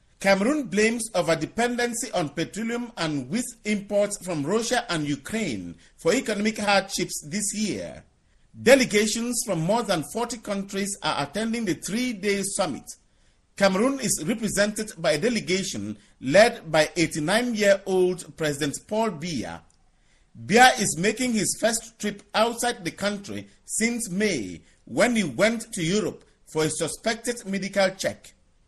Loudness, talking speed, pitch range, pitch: -24 LUFS, 130 wpm, 165-230 Hz, 205 Hz